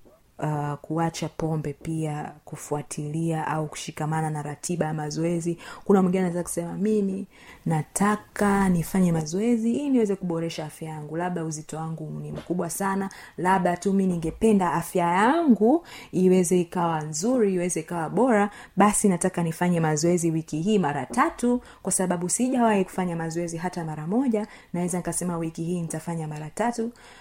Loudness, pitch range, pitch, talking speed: -25 LUFS, 160-200 Hz, 175 Hz, 135 wpm